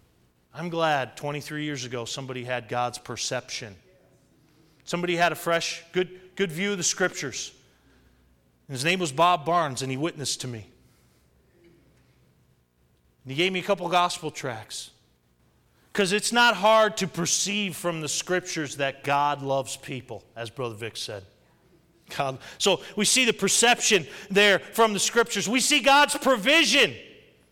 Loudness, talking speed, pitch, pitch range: -24 LUFS, 150 wpm, 160 Hz, 125-190 Hz